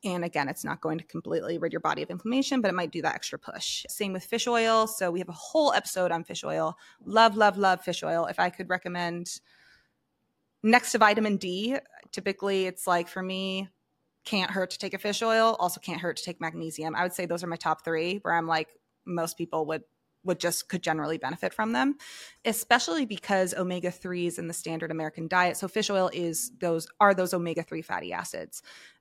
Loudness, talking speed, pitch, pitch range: -28 LUFS, 210 wpm, 180 Hz, 170-205 Hz